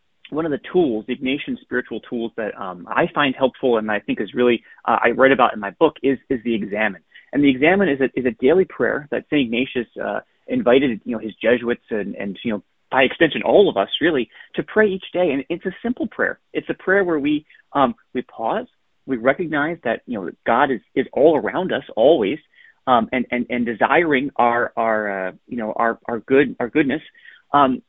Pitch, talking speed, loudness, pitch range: 130 Hz, 220 wpm, -20 LUFS, 120-150 Hz